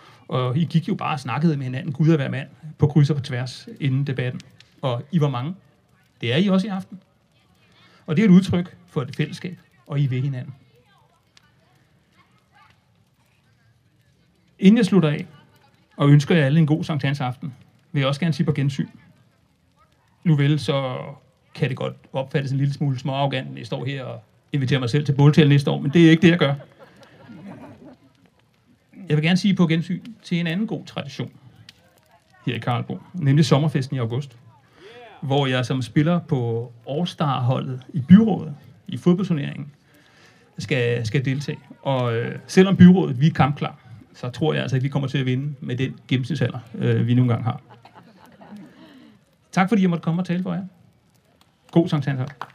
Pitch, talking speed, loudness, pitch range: 145 Hz, 180 wpm, -21 LUFS, 130-165 Hz